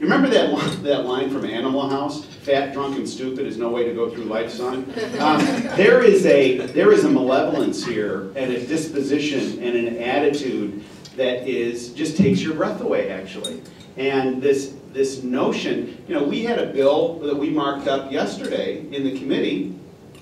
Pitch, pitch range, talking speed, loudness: 135 Hz, 125-150 Hz, 180 wpm, -21 LUFS